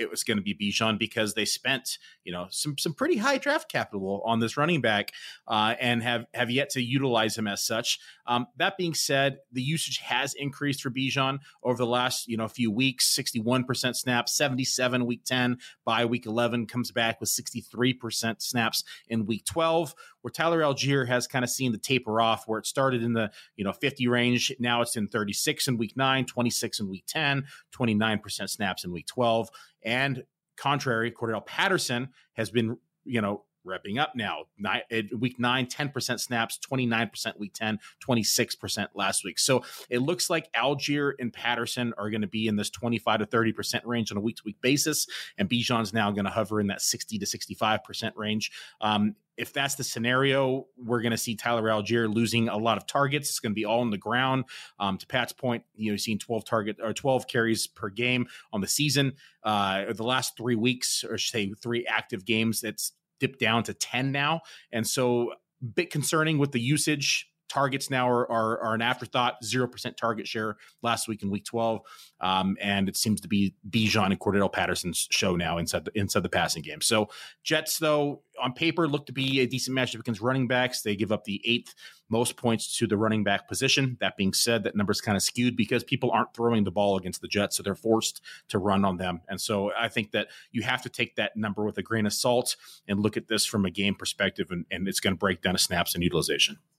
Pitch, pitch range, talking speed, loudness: 120 Hz, 110-130 Hz, 210 wpm, -27 LUFS